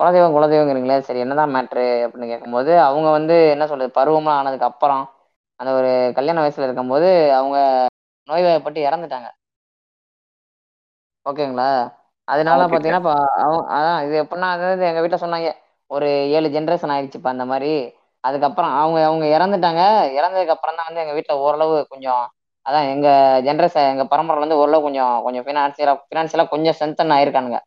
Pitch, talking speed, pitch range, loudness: 150 Hz, 140 wpm, 135-160 Hz, -17 LUFS